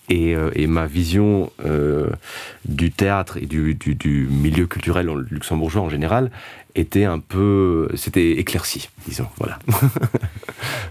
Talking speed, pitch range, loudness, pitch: 125 wpm, 80-105 Hz, -20 LUFS, 90 Hz